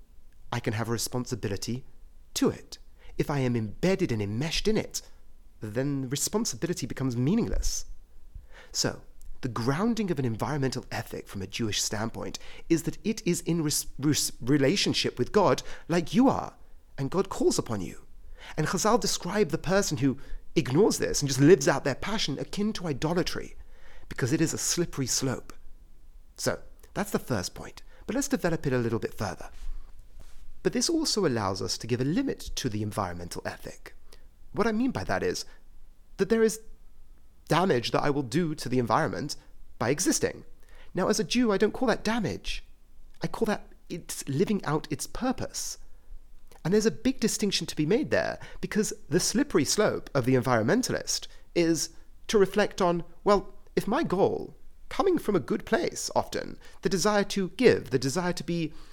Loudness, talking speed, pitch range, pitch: -28 LUFS, 175 wpm, 125-200 Hz, 155 Hz